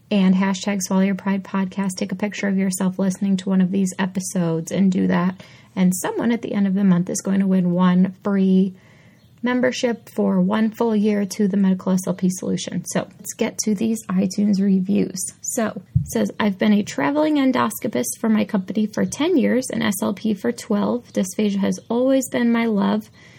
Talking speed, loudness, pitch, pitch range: 190 wpm, -21 LUFS, 200 Hz, 190-220 Hz